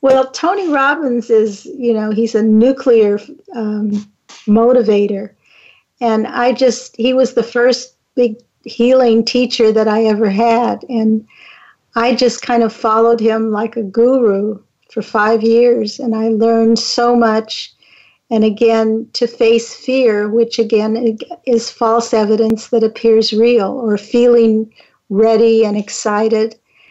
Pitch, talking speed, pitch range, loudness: 230 Hz, 135 wpm, 220-240 Hz, -13 LUFS